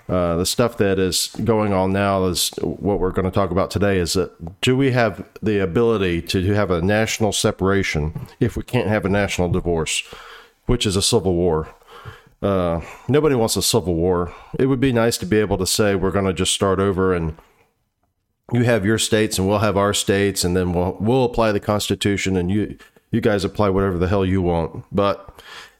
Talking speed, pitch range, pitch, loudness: 220 wpm, 90-110 Hz, 100 Hz, -20 LUFS